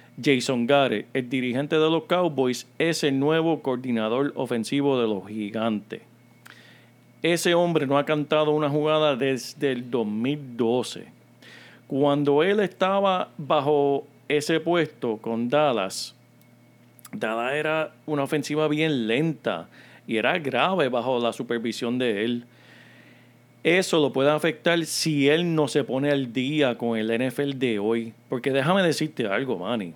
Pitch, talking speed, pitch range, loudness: 140 Hz, 135 wpm, 120-155 Hz, -24 LUFS